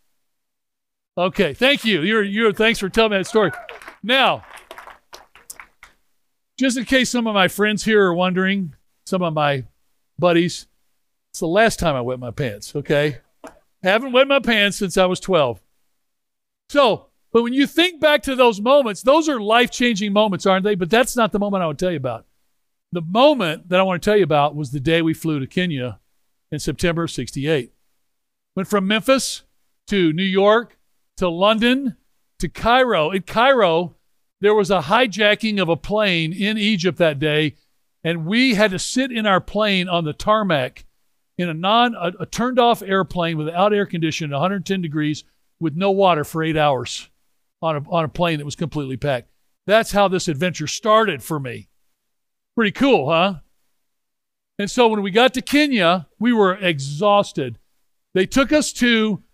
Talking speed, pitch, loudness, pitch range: 180 wpm, 190 Hz, -18 LUFS, 165-225 Hz